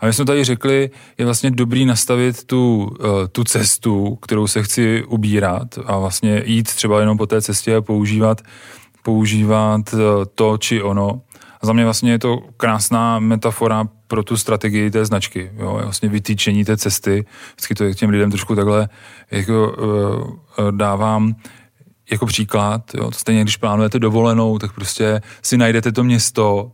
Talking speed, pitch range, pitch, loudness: 155 wpm, 105-115 Hz, 110 Hz, -17 LUFS